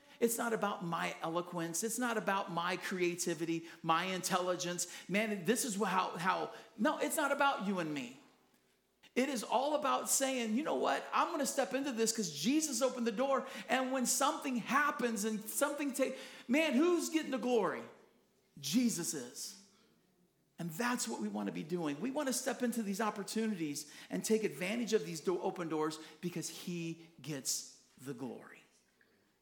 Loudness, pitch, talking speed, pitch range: -36 LUFS, 220 Hz, 175 wpm, 175-255 Hz